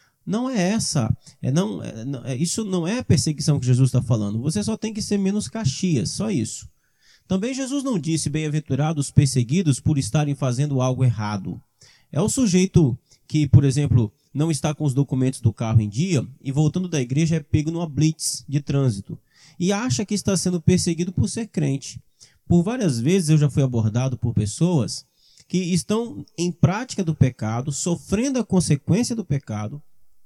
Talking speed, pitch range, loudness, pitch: 180 wpm, 130-180 Hz, -22 LUFS, 150 Hz